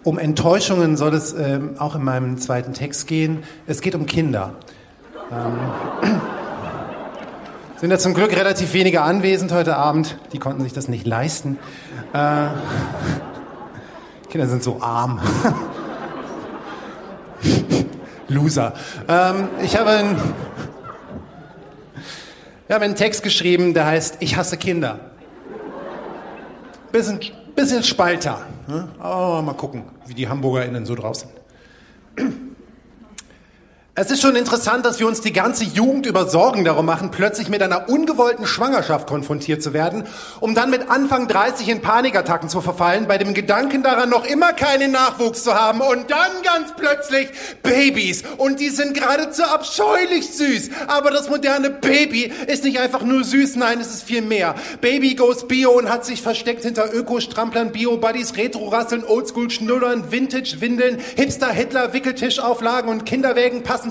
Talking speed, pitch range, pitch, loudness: 140 wpm, 155-250 Hz, 220 Hz, -18 LUFS